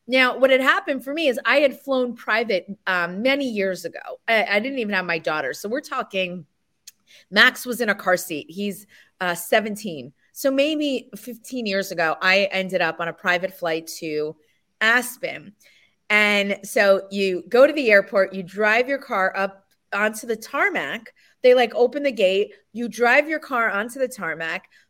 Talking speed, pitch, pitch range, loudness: 180 wpm, 210 Hz, 190-250 Hz, -21 LUFS